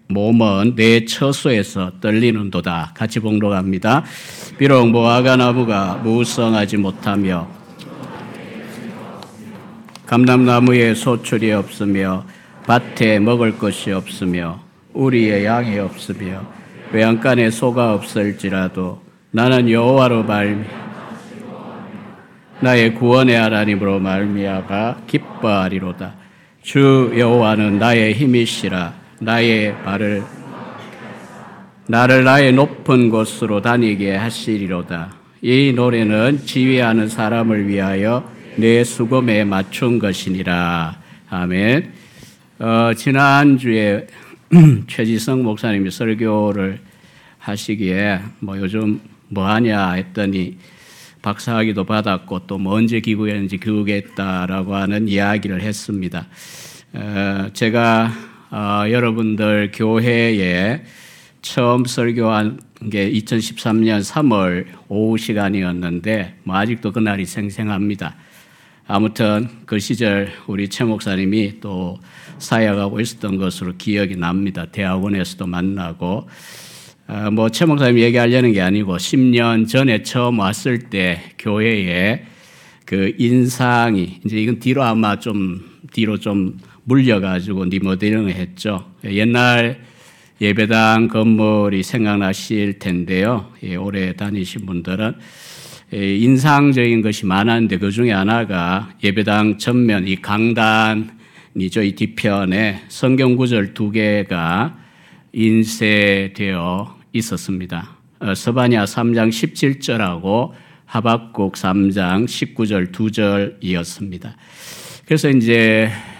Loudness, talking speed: -16 LUFS, 230 characters per minute